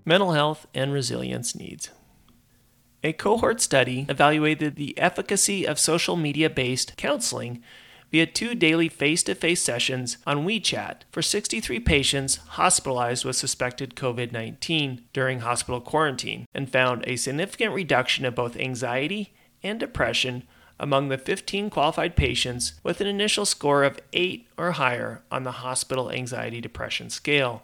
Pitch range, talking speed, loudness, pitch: 125-160 Hz, 140 wpm, -24 LUFS, 135 Hz